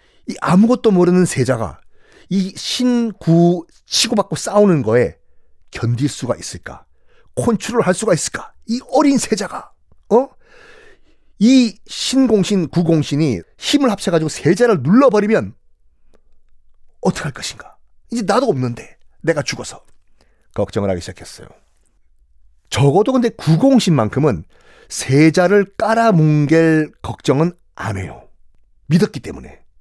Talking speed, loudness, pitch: 255 characters per minute, -16 LUFS, 170 Hz